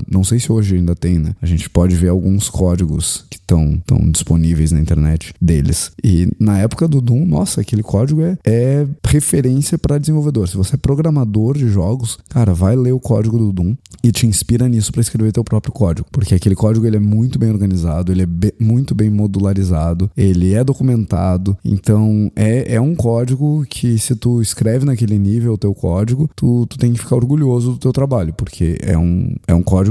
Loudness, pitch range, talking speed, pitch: -15 LUFS, 95-125 Hz, 200 wpm, 110 Hz